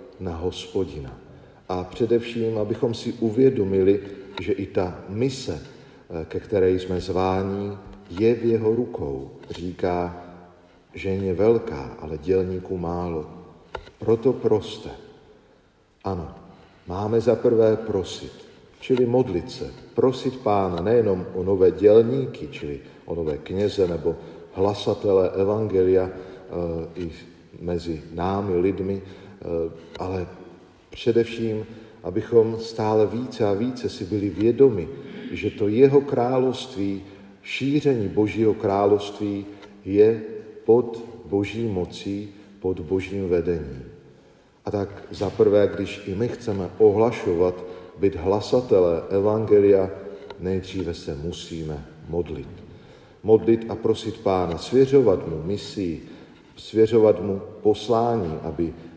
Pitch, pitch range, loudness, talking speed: 100 Hz, 90-115 Hz, -23 LUFS, 105 wpm